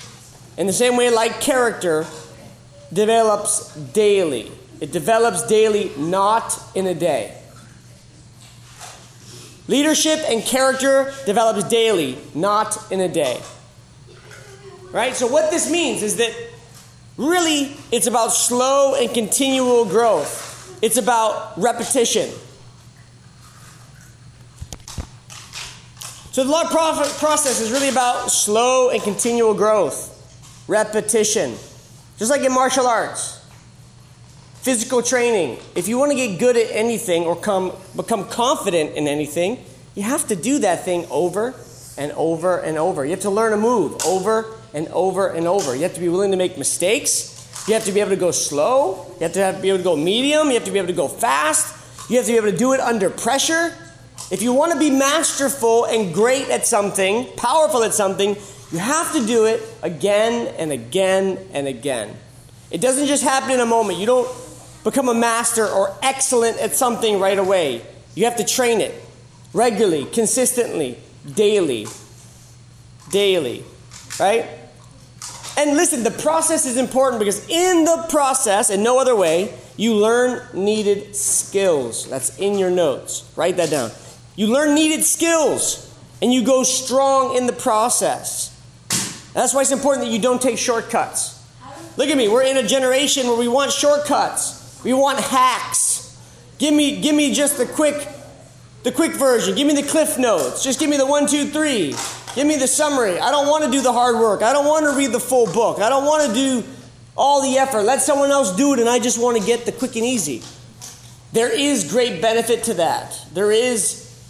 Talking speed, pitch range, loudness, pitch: 170 wpm, 180-265 Hz, -18 LUFS, 230 Hz